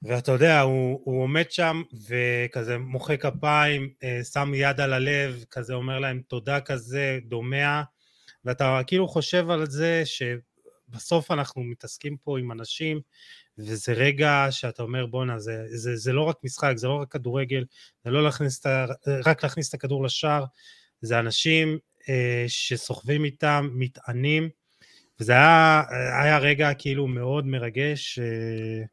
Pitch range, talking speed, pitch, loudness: 125-150 Hz, 145 wpm, 135 Hz, -24 LUFS